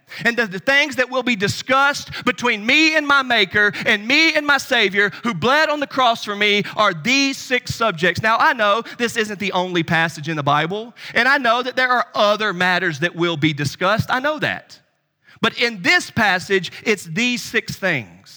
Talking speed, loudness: 205 wpm, -17 LUFS